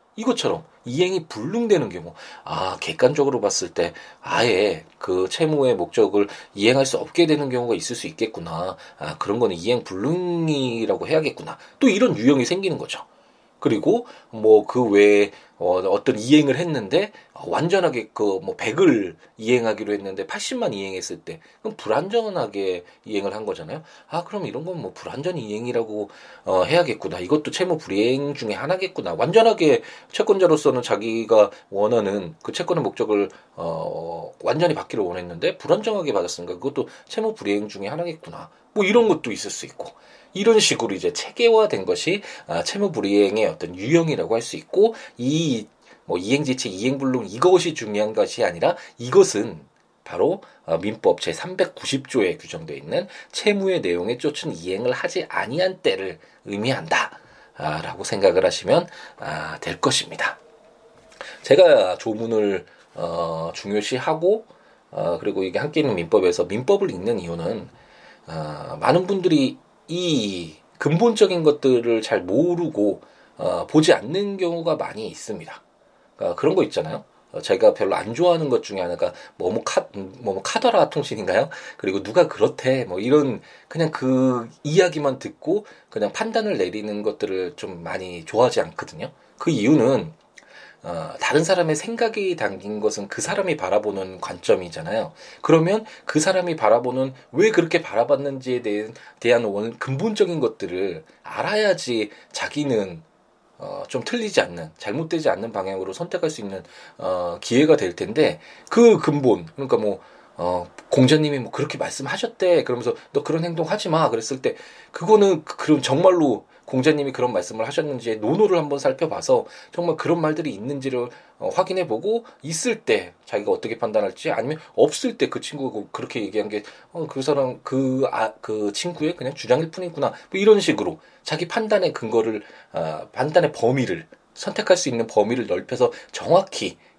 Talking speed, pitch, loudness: 330 characters per minute, 155 Hz, -22 LUFS